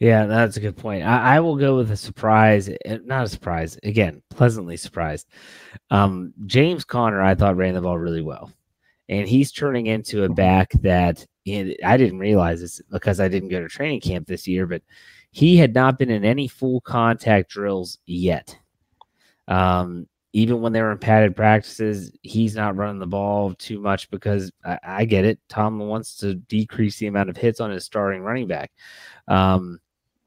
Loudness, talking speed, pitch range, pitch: -21 LUFS, 185 wpm, 95-115 Hz, 105 Hz